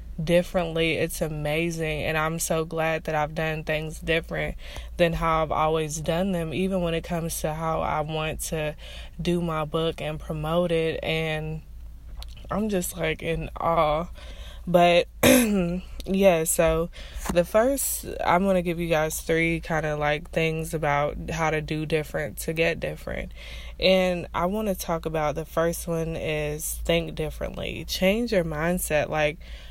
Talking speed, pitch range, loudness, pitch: 160 wpm, 155-175 Hz, -25 LUFS, 165 Hz